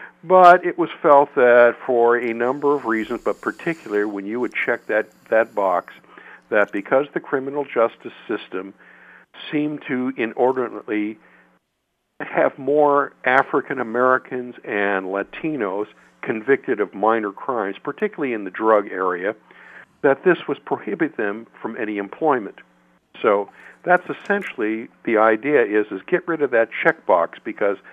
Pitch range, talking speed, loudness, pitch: 105-145 Hz, 140 wpm, -20 LUFS, 120 Hz